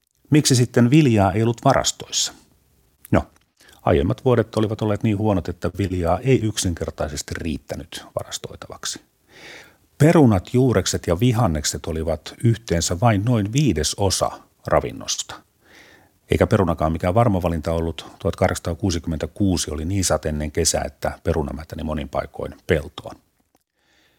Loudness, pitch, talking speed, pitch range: -21 LUFS, 95 Hz, 115 wpm, 80-115 Hz